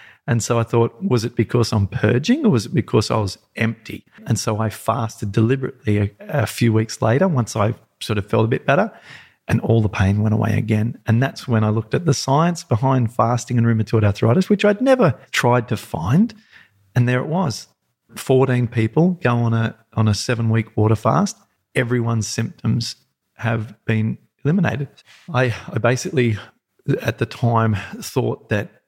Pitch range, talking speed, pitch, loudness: 110-130 Hz, 185 wpm, 115 Hz, -19 LUFS